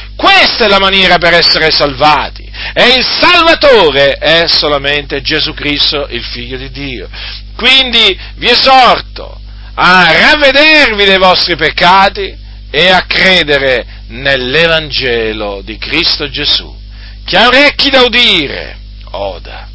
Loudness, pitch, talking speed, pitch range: -6 LUFS, 155 Hz, 120 wpm, 135-220 Hz